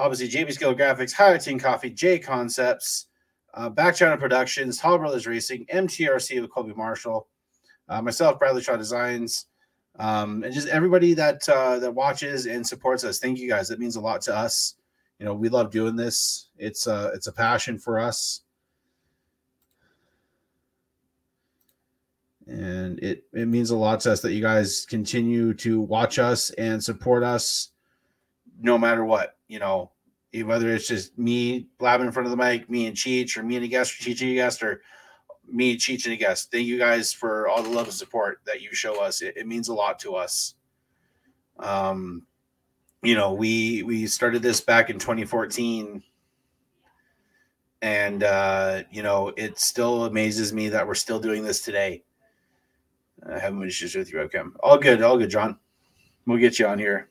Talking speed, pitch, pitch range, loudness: 180 wpm, 120 Hz, 110-125 Hz, -24 LUFS